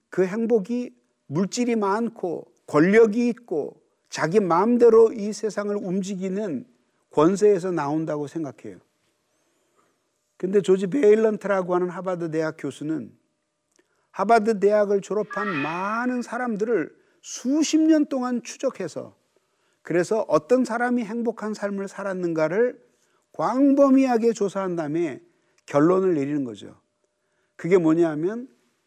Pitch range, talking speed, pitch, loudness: 180-235 Hz, 265 characters per minute, 205 Hz, -23 LUFS